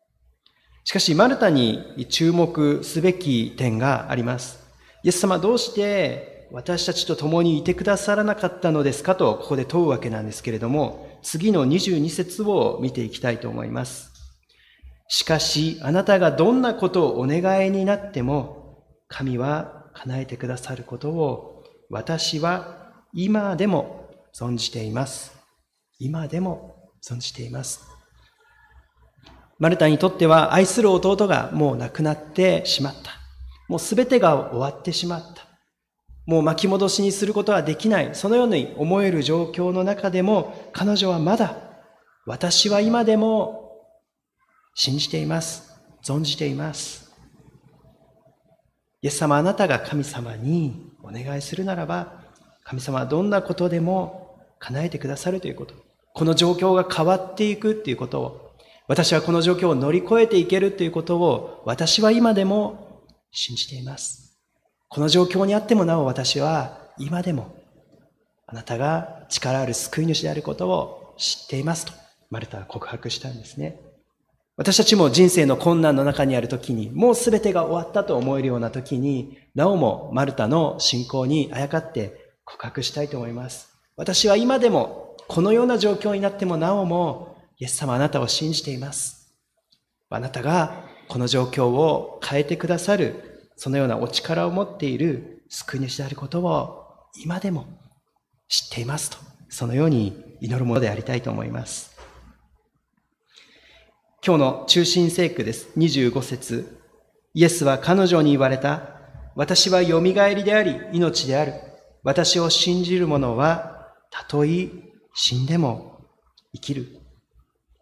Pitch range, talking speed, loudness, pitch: 135-185 Hz, 290 characters per minute, -21 LUFS, 160 Hz